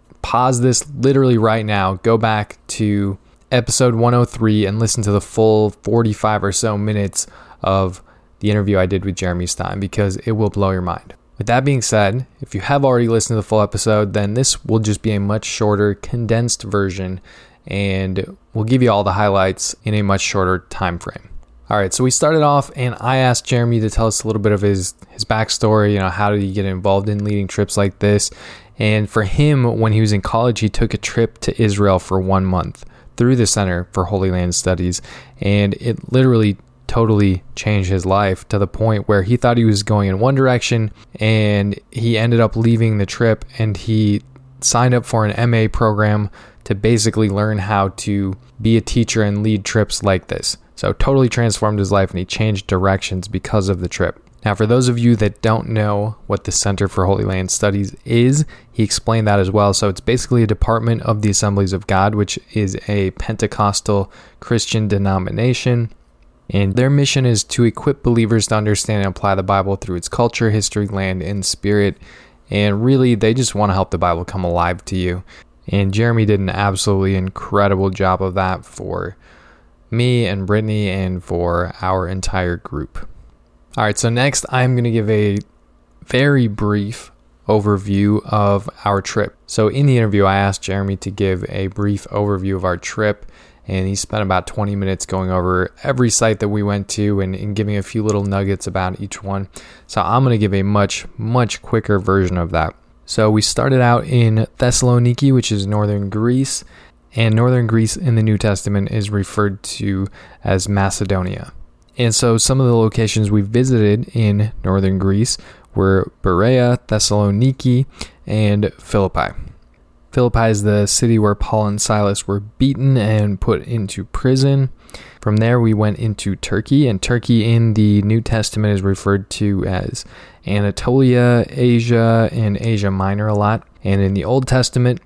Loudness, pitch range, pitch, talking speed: -17 LUFS, 95-115 Hz, 105 Hz, 185 wpm